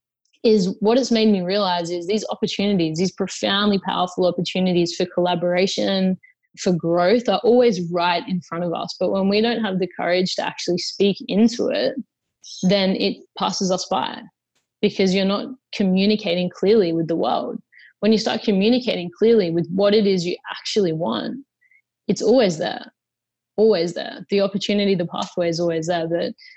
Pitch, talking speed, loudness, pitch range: 195 Hz, 165 wpm, -20 LUFS, 175-215 Hz